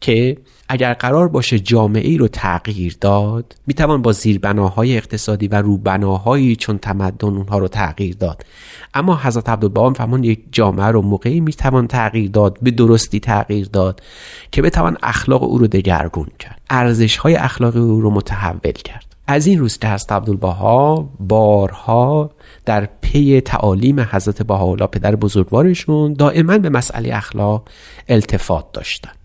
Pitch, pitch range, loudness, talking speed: 110 Hz, 100-130 Hz, -15 LUFS, 145 wpm